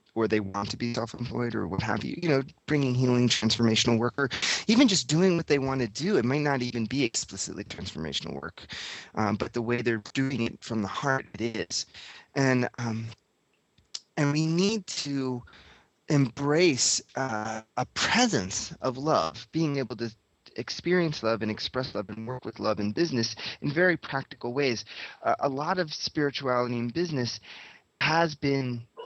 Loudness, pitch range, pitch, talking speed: -28 LUFS, 115-145 Hz, 125 Hz, 175 wpm